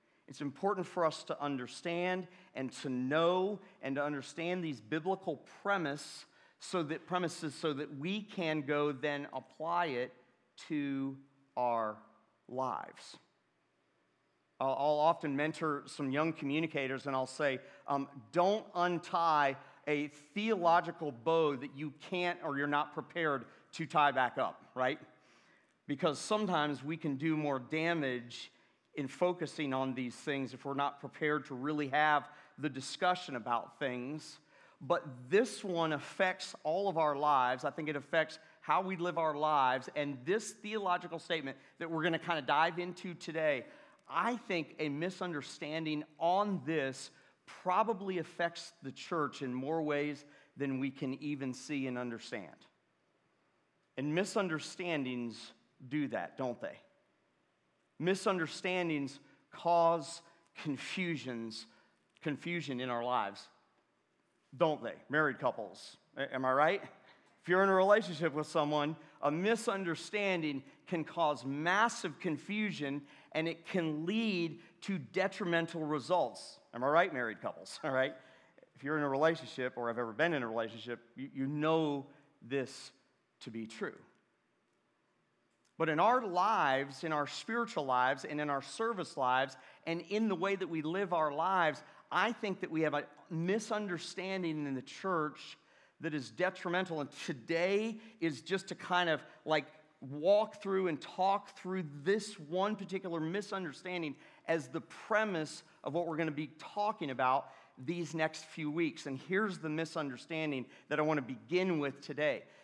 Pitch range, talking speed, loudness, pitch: 140-175 Hz, 145 wpm, -36 LUFS, 155 Hz